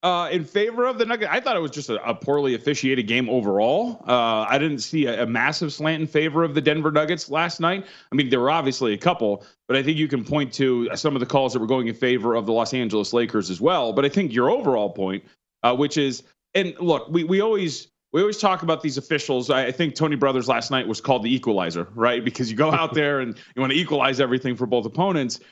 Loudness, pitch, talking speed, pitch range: -22 LUFS, 140 Hz, 255 wpm, 125-160 Hz